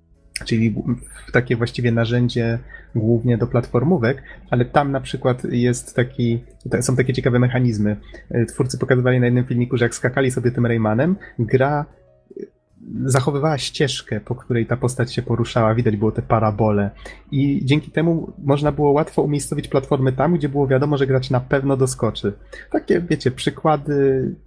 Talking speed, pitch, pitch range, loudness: 150 wpm, 125 Hz, 120-140 Hz, -20 LUFS